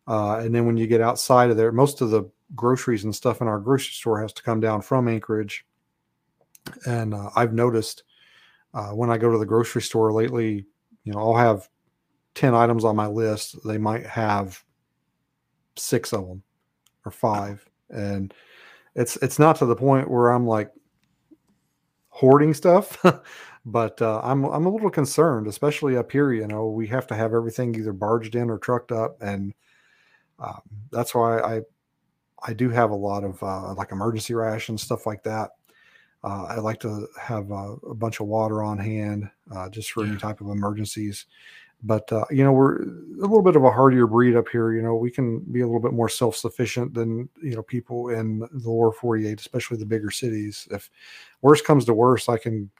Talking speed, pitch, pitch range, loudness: 195 wpm, 115 Hz, 110-125 Hz, -22 LUFS